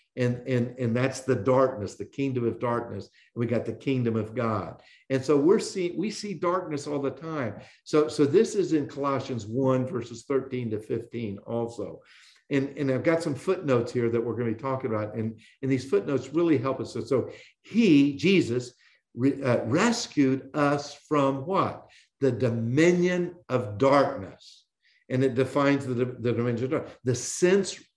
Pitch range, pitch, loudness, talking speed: 120-145 Hz, 130 Hz, -27 LUFS, 180 wpm